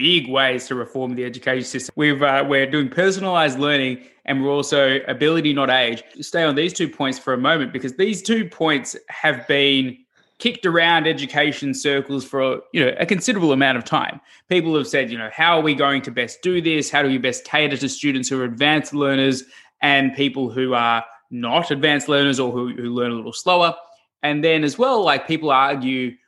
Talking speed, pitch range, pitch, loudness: 205 wpm, 130-155 Hz, 140 Hz, -19 LUFS